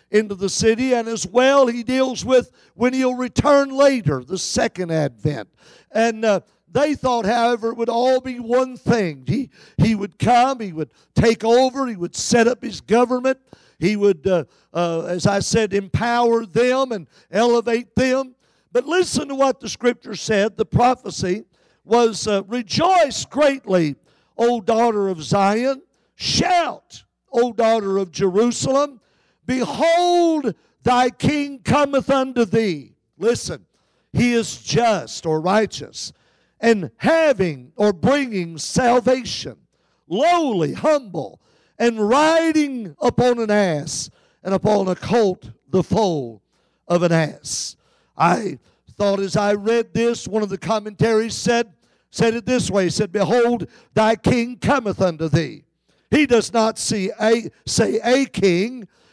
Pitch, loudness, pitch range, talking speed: 230 Hz, -19 LUFS, 195-250 Hz, 140 wpm